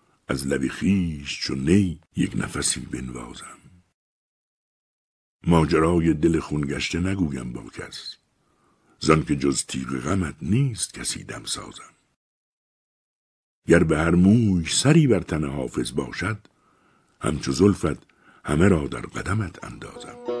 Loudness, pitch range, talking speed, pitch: -23 LUFS, 70-90 Hz, 120 wpm, 80 Hz